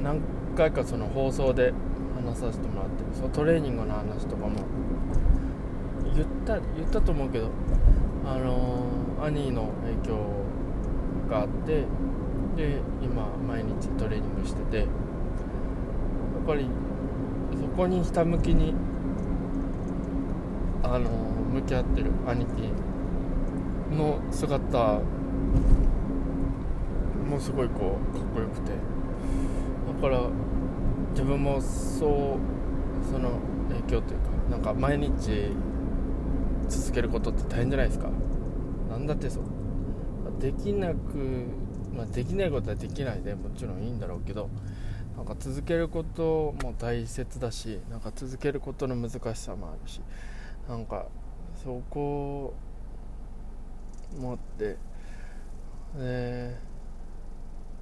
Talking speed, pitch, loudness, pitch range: 220 characters per minute, 120 Hz, -30 LUFS, 95-135 Hz